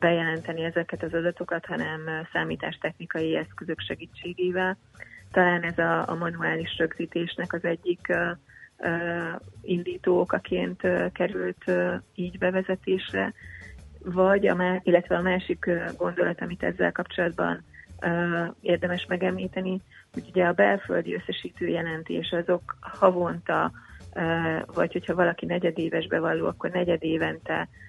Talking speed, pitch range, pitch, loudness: 115 wpm, 160-180 Hz, 170 Hz, -27 LUFS